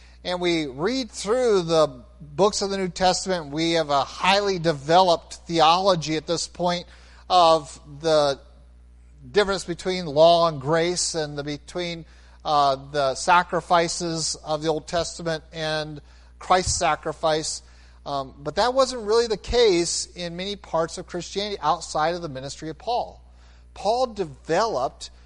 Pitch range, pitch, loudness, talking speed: 145-180 Hz, 165 Hz, -23 LUFS, 140 wpm